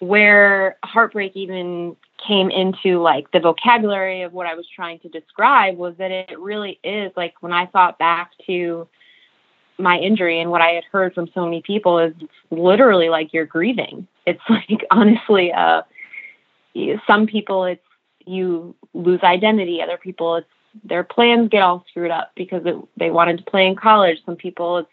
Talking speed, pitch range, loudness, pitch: 175 wpm, 170-200 Hz, -17 LUFS, 180 Hz